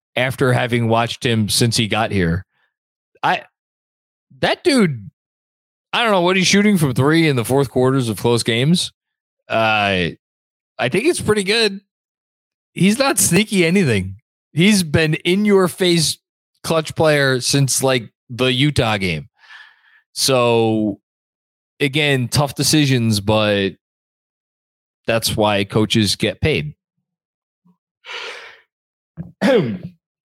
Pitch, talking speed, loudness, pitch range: 135 Hz, 115 wpm, -17 LUFS, 115-180 Hz